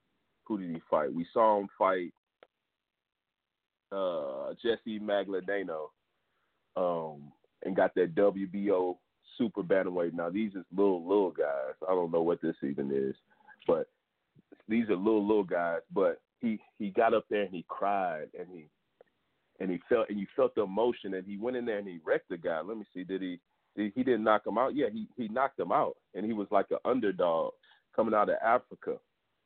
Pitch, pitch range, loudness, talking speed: 100 Hz, 90-120 Hz, -32 LUFS, 195 wpm